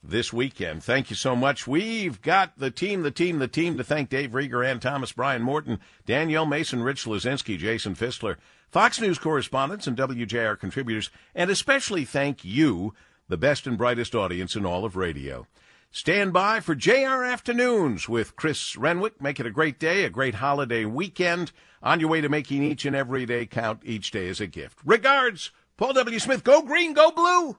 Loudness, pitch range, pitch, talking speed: -24 LUFS, 120-180 Hz, 140 Hz, 190 wpm